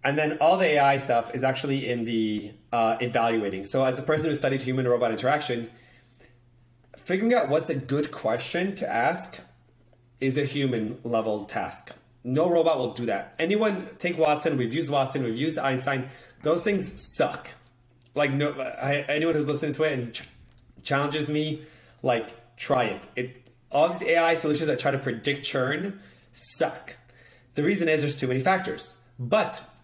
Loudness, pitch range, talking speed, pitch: -26 LUFS, 120-150 Hz, 170 wpm, 135 Hz